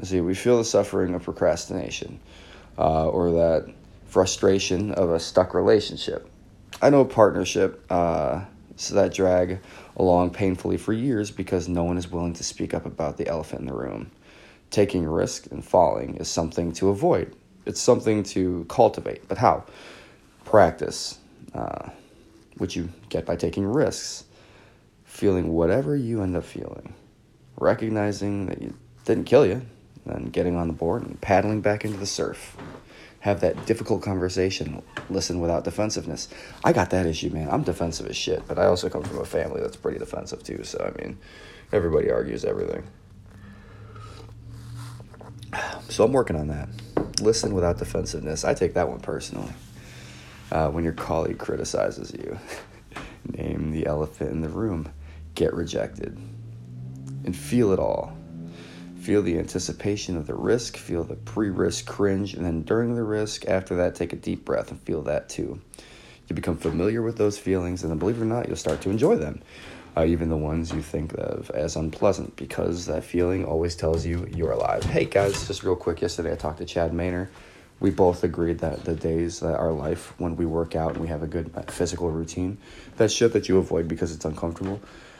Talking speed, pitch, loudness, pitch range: 175 wpm, 90 Hz, -25 LUFS, 85-105 Hz